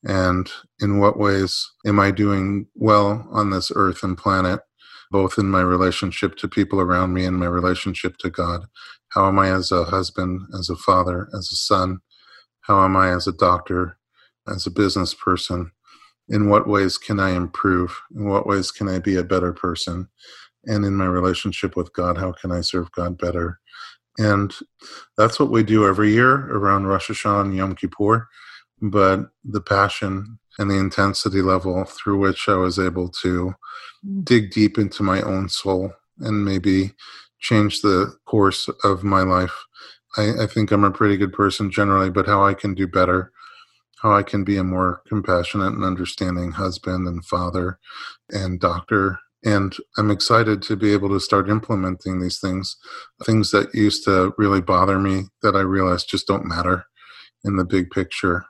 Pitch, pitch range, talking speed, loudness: 95 Hz, 90-100 Hz, 175 wpm, -20 LUFS